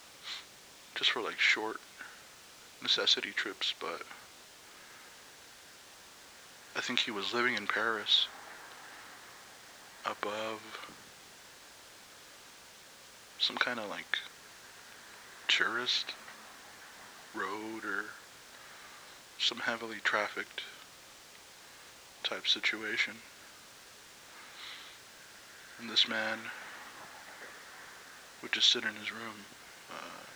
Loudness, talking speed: -32 LUFS, 70 wpm